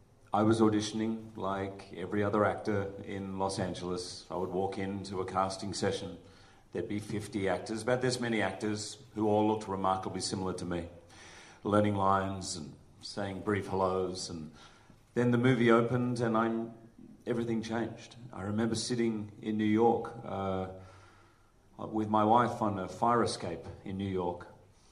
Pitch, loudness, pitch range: 105 Hz, -32 LUFS, 95-115 Hz